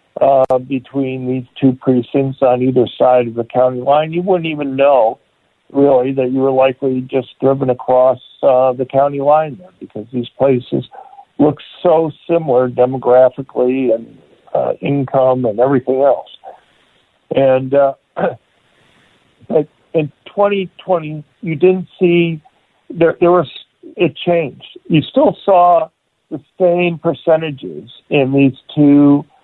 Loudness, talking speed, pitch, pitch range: -14 LUFS, 130 wpm, 140 Hz, 130-165 Hz